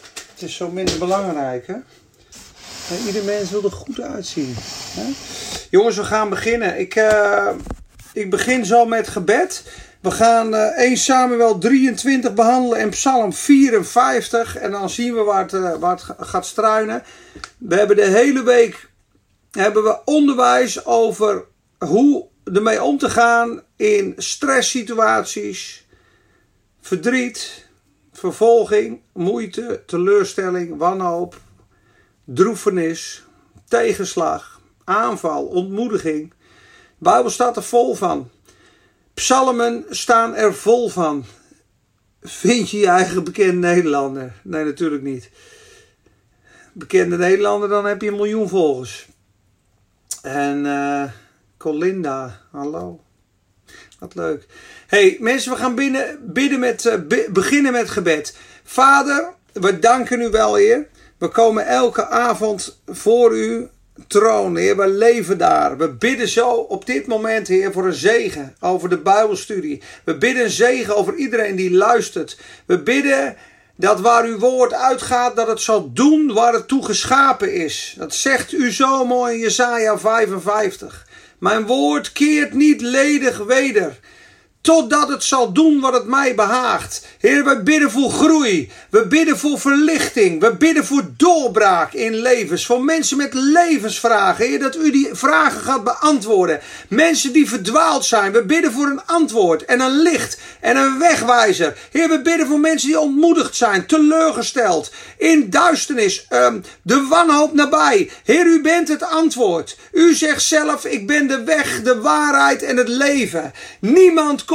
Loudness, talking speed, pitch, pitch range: -16 LUFS, 140 wpm, 235 Hz, 200-290 Hz